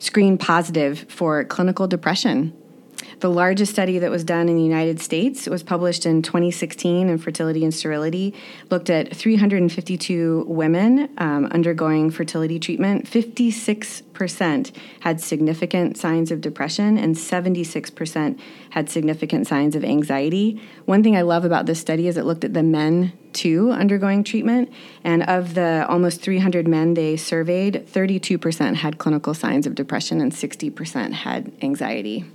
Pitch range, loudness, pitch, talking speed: 160-200 Hz, -20 LUFS, 175 Hz, 145 wpm